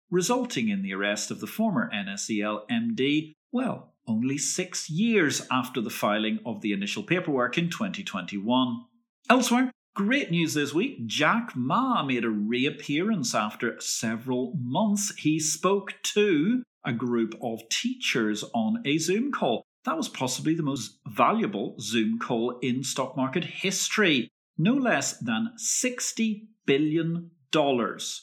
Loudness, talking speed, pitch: -27 LUFS, 135 wpm, 165 Hz